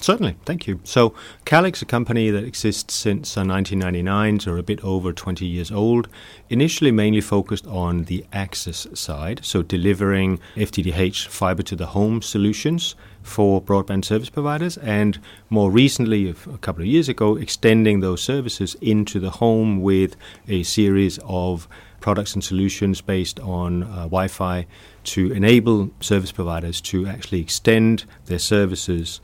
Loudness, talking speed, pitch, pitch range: -20 LUFS, 150 wpm, 100 Hz, 95-110 Hz